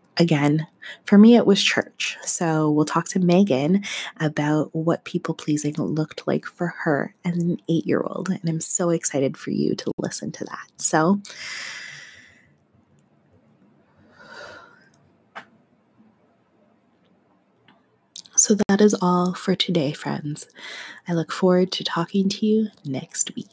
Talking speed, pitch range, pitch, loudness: 125 wpm, 155-195 Hz, 175 Hz, -21 LUFS